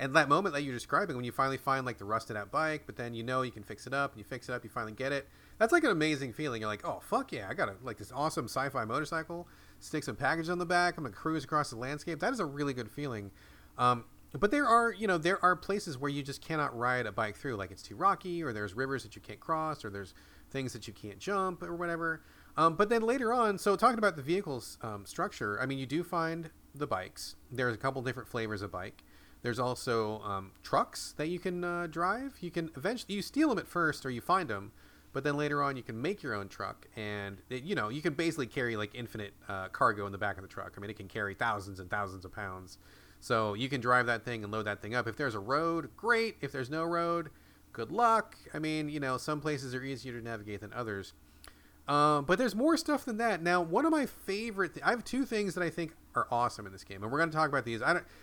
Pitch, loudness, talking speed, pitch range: 135 Hz, -33 LUFS, 265 wpm, 110-170 Hz